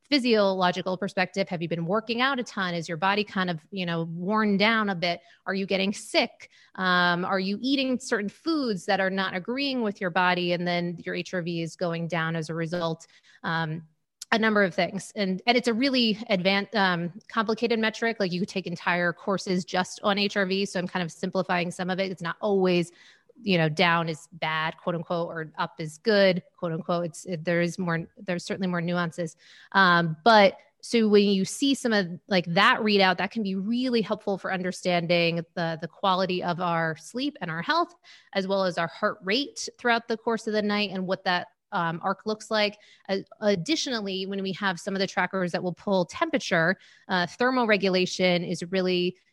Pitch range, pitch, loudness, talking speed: 175-210 Hz, 190 Hz, -26 LUFS, 205 wpm